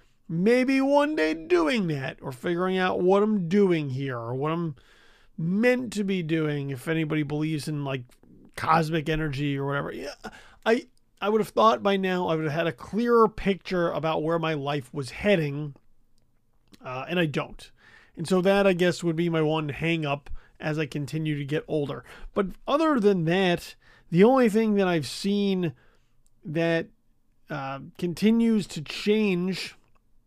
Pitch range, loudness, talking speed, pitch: 145-195 Hz, -25 LUFS, 170 wpm, 165 Hz